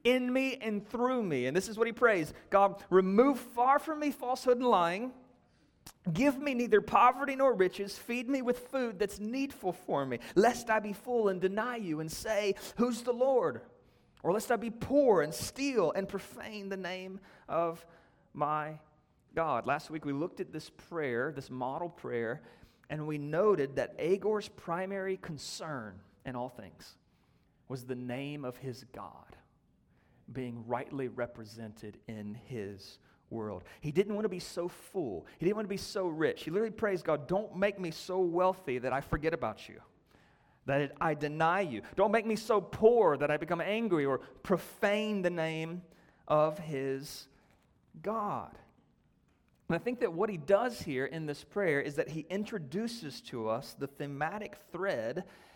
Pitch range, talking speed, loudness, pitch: 145-220 Hz, 170 wpm, -33 LUFS, 185 Hz